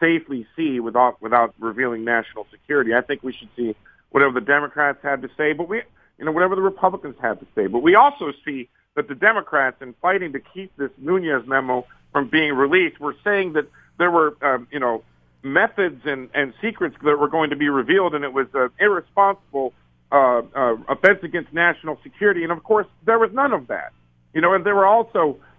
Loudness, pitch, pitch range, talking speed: -20 LUFS, 150 Hz, 130-190 Hz, 210 wpm